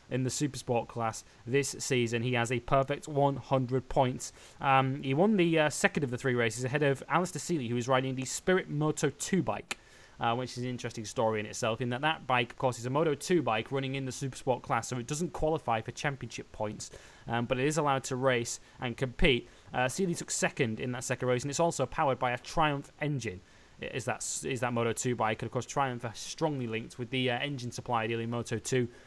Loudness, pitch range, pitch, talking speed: -31 LUFS, 120-140 Hz, 130 Hz, 230 wpm